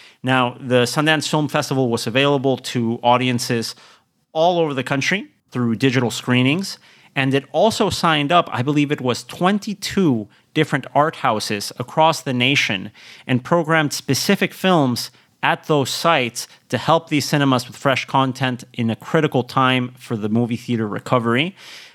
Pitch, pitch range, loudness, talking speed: 135 Hz, 125-155 Hz, -19 LUFS, 150 wpm